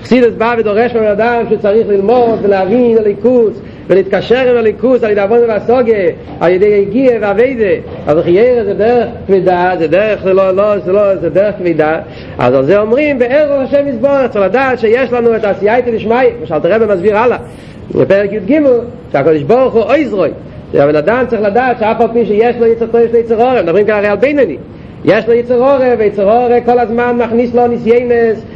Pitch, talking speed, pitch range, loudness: 230 Hz, 190 wpm, 205-245 Hz, -10 LUFS